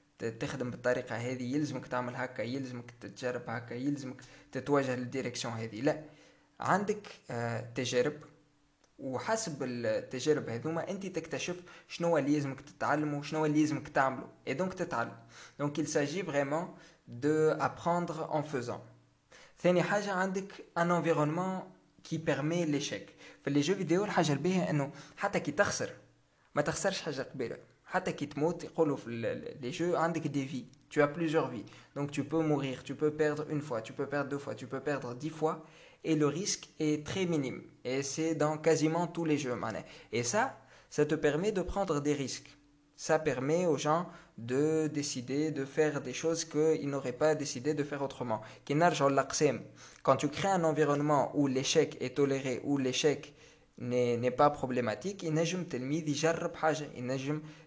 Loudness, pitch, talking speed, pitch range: -33 LUFS, 150 Hz, 150 wpm, 130-160 Hz